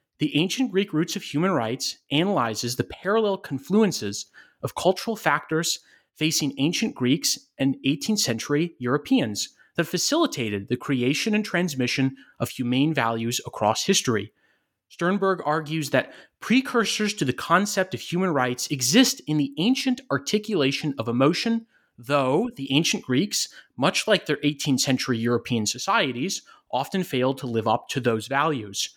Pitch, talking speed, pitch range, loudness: 150 Hz, 140 wpm, 125-195 Hz, -24 LUFS